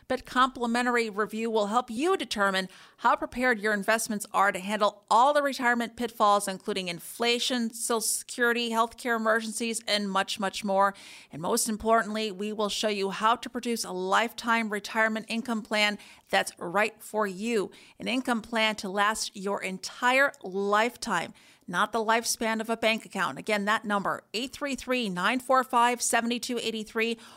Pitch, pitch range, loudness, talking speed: 225 Hz, 205-235 Hz, -27 LUFS, 145 wpm